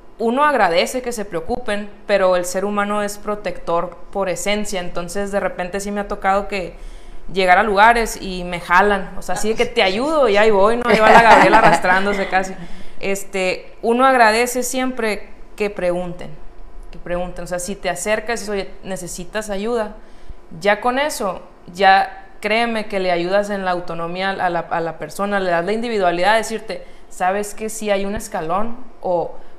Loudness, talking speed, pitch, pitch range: -18 LUFS, 180 wpm, 200 Hz, 180-215 Hz